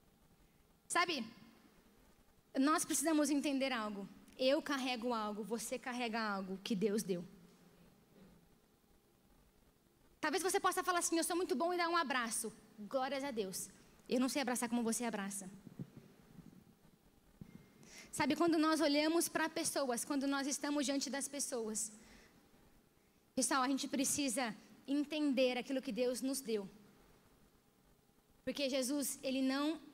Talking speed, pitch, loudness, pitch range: 125 wpm, 260 Hz, -37 LUFS, 215-290 Hz